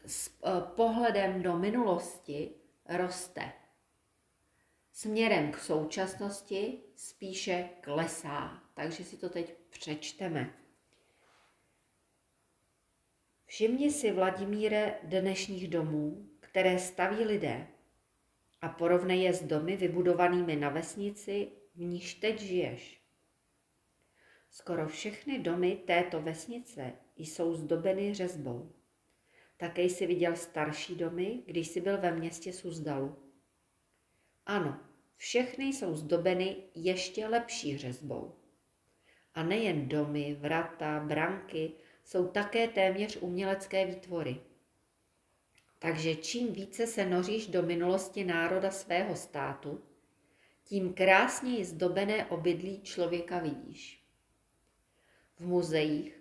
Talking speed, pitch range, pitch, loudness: 95 wpm, 160-195 Hz, 180 Hz, -33 LUFS